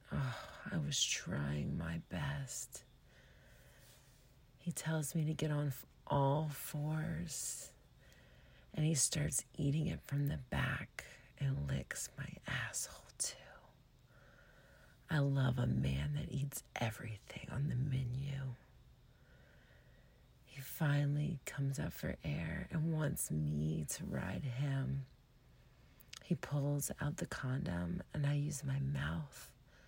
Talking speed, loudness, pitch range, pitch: 120 wpm, -39 LUFS, 125-150 Hz, 140 Hz